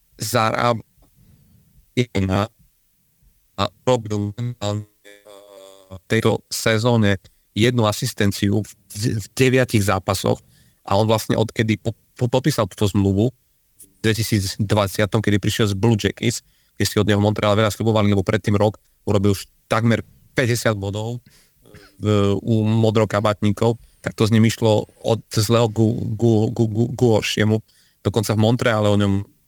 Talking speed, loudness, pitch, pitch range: 115 wpm, -20 LUFS, 110 Hz, 105-115 Hz